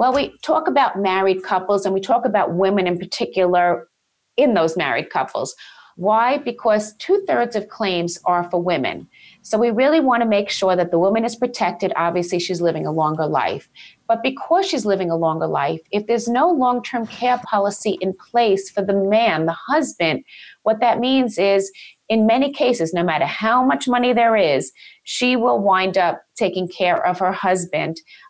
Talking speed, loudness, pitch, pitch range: 185 wpm, -19 LUFS, 205 Hz, 185-245 Hz